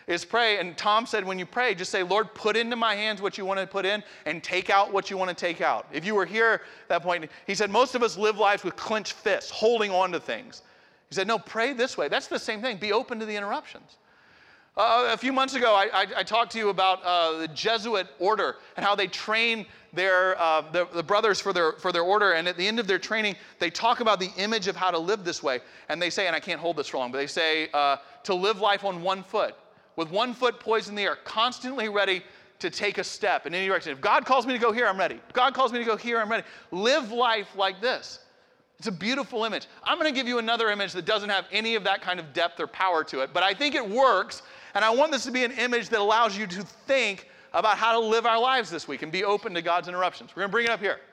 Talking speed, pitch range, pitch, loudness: 275 wpm, 185-230 Hz, 205 Hz, -26 LUFS